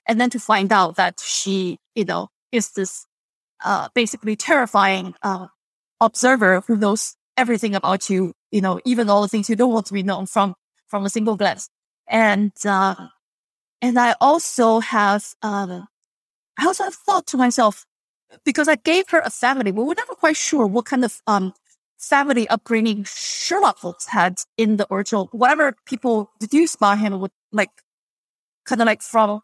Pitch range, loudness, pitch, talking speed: 200-250 Hz, -19 LUFS, 220 Hz, 175 wpm